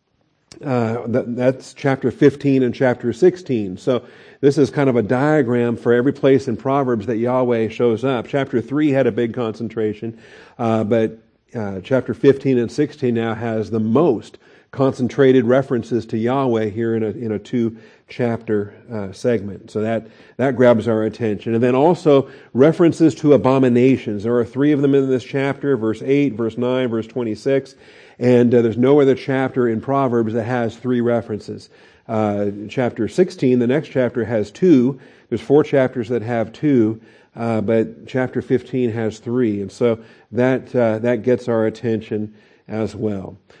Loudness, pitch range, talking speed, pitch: -18 LUFS, 110-130 Hz, 165 wpm, 120 Hz